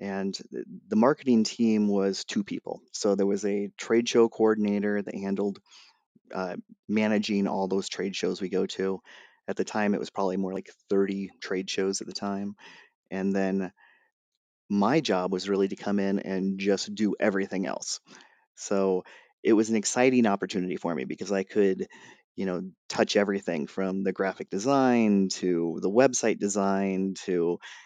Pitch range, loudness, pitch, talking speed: 95-105 Hz, -27 LUFS, 100 Hz, 165 wpm